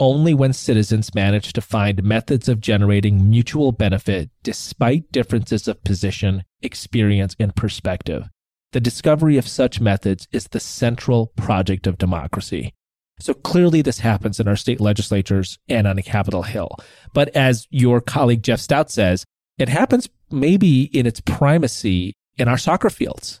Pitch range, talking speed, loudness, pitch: 100-130 Hz, 150 wpm, -19 LUFS, 110 Hz